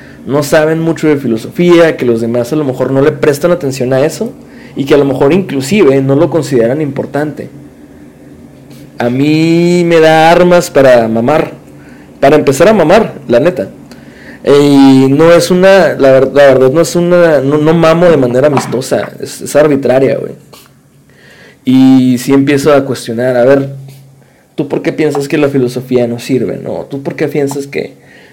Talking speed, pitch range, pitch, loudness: 180 wpm, 130-160 Hz, 140 Hz, -8 LUFS